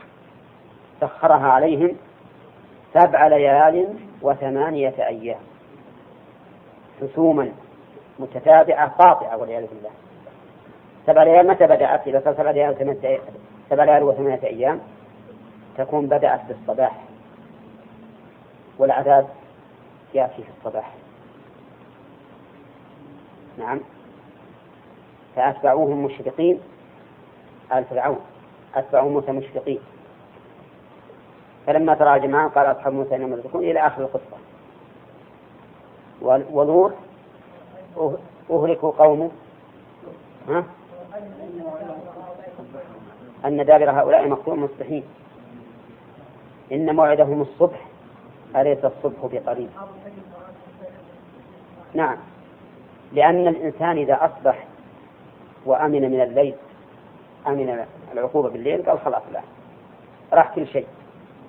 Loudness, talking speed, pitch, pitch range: -19 LUFS, 80 wpm, 145 Hz, 135-165 Hz